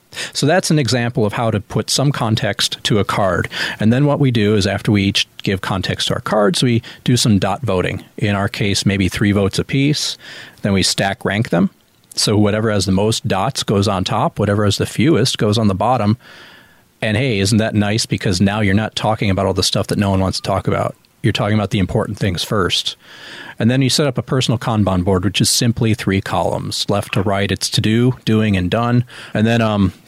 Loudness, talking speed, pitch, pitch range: -16 LUFS, 230 wpm, 110 Hz, 100-120 Hz